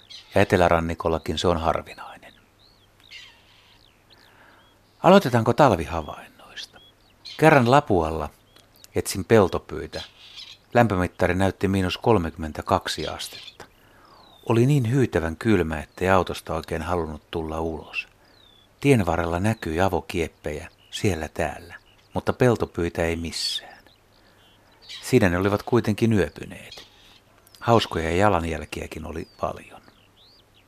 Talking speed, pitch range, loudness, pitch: 90 wpm, 85-110 Hz, -23 LUFS, 100 Hz